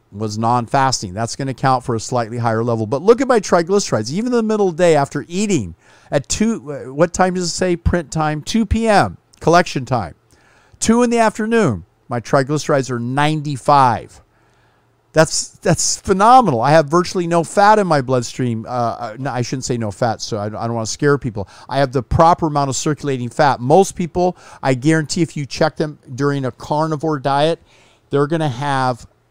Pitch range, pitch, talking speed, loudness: 120-175 Hz, 145 Hz, 200 wpm, -17 LUFS